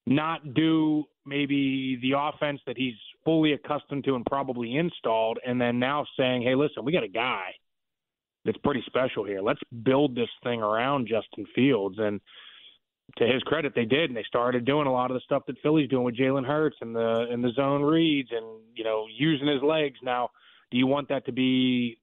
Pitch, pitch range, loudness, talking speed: 135 Hz, 120-145 Hz, -27 LUFS, 200 wpm